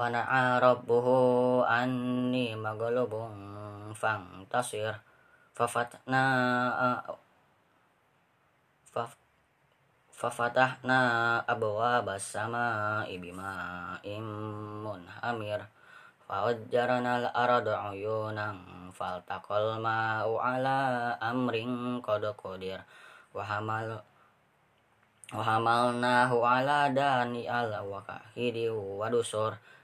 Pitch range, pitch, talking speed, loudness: 105-125 Hz, 115 Hz, 65 wpm, -30 LUFS